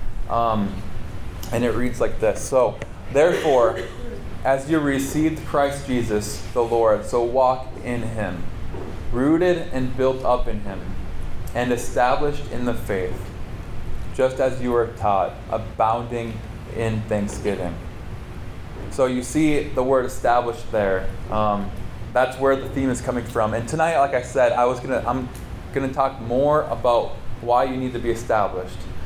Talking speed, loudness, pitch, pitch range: 150 wpm, -22 LUFS, 120 Hz, 105-130 Hz